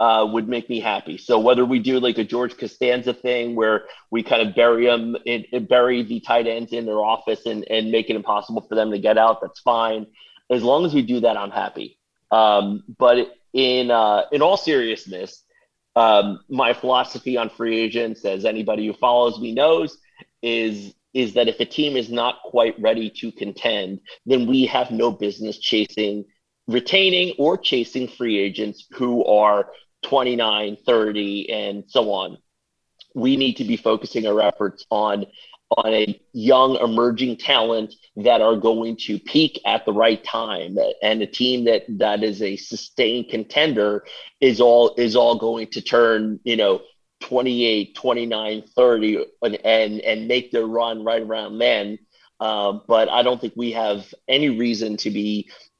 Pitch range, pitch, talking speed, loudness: 110-125 Hz, 115 Hz, 175 wpm, -20 LUFS